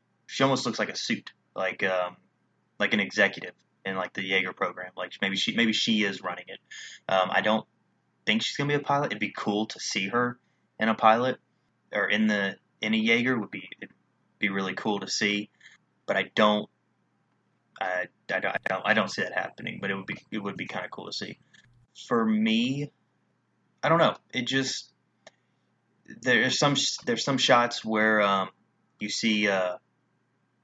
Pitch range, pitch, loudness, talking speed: 95-125 Hz, 110 Hz, -27 LUFS, 190 wpm